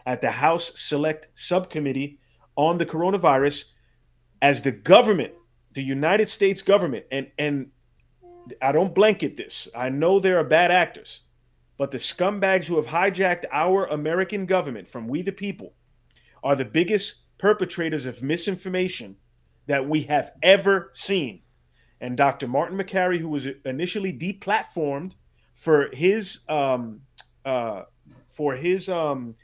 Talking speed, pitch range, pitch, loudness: 135 wpm, 135-185 Hz, 155 Hz, -23 LUFS